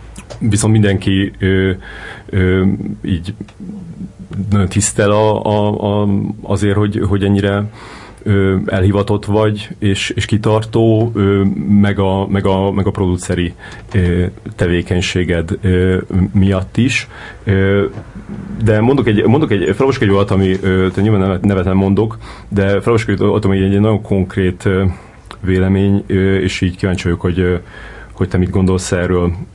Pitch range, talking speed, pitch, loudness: 95-105 Hz, 130 wpm, 100 Hz, -14 LUFS